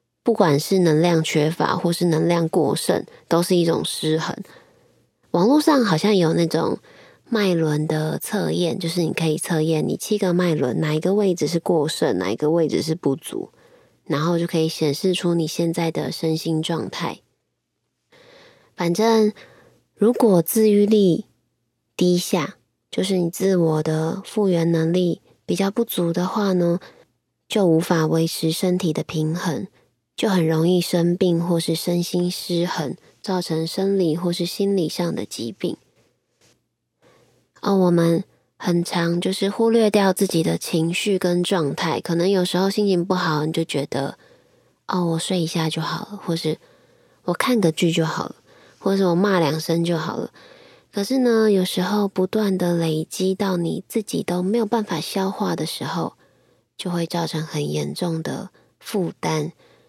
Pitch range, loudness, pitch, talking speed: 160-195 Hz, -21 LUFS, 175 Hz, 230 characters per minute